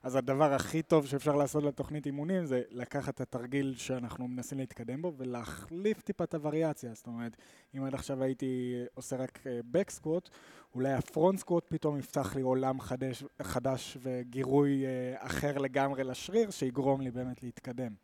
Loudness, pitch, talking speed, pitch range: -34 LUFS, 135 Hz, 155 wpm, 125-150 Hz